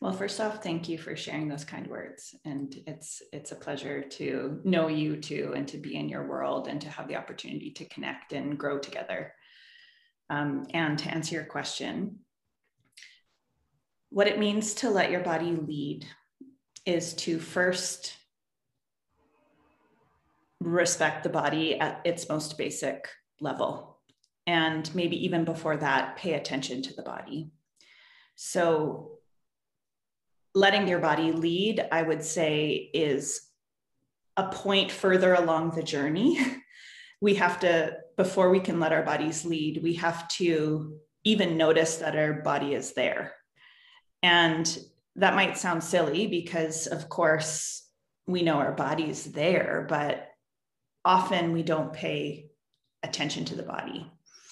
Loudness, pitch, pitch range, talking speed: -28 LUFS, 165 Hz, 155-185 Hz, 140 wpm